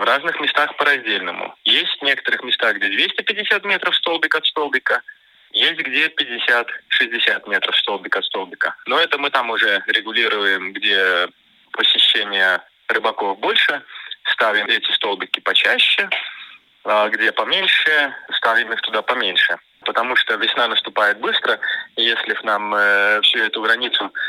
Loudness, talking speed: -17 LUFS, 135 wpm